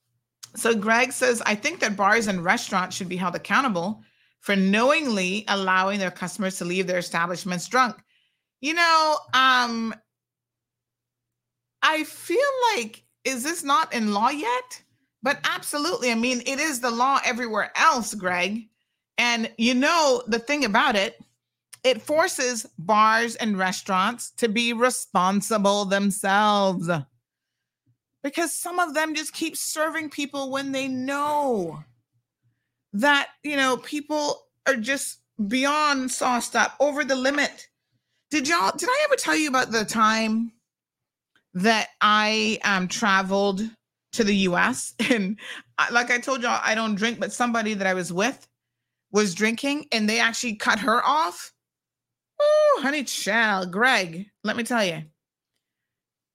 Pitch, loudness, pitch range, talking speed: 230 Hz, -23 LUFS, 190-270 Hz, 140 wpm